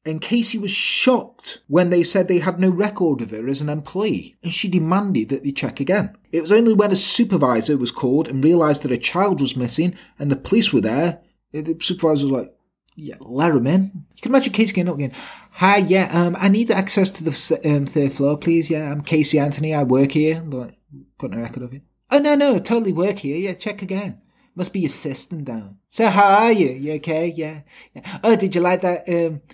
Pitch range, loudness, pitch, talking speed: 145-195 Hz, -19 LUFS, 170 Hz, 225 wpm